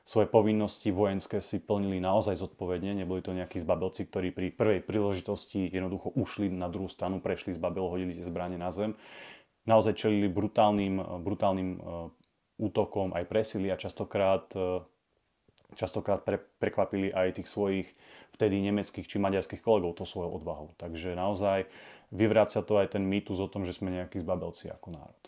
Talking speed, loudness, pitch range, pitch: 155 wpm, -31 LUFS, 90-105 Hz, 95 Hz